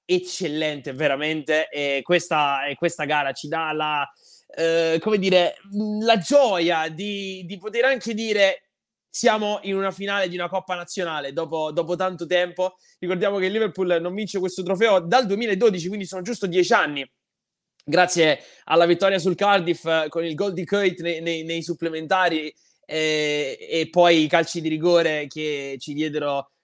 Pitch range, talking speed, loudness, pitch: 155-195 Hz, 155 wpm, -22 LUFS, 175 Hz